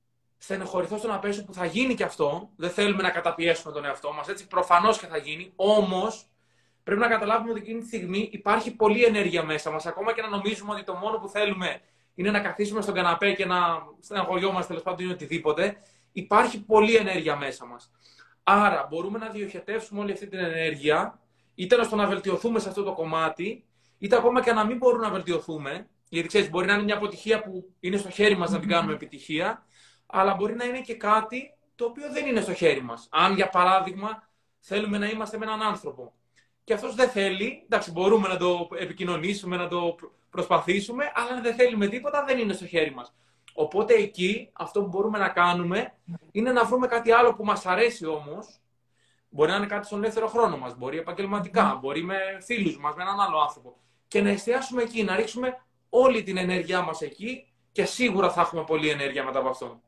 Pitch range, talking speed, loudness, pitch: 170-220 Hz, 200 wpm, -26 LUFS, 195 Hz